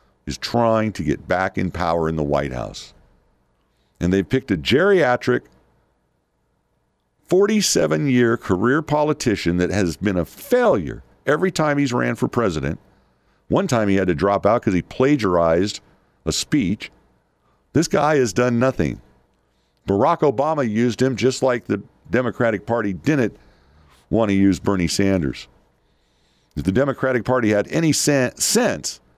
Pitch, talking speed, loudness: 95 Hz, 145 wpm, -20 LUFS